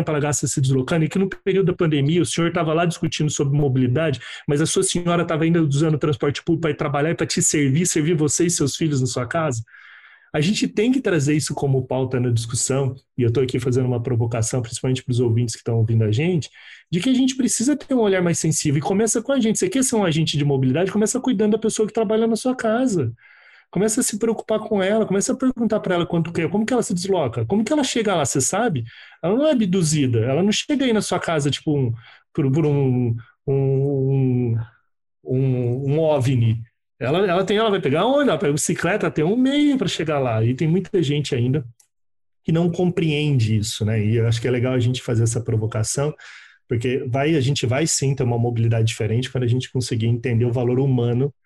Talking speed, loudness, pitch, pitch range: 230 wpm, -20 LUFS, 150 Hz, 130-190 Hz